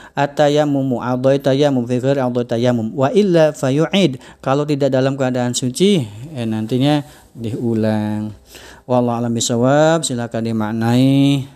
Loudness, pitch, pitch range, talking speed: -17 LUFS, 130 Hz, 120-140 Hz, 120 wpm